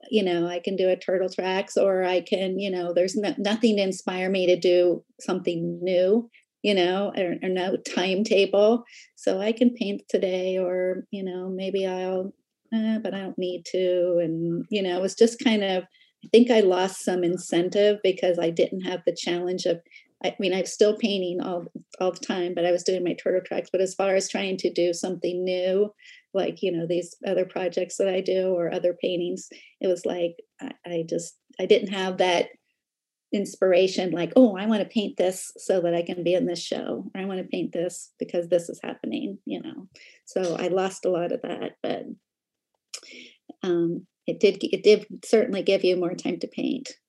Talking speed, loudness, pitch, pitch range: 205 wpm, -25 LUFS, 185 Hz, 180-205 Hz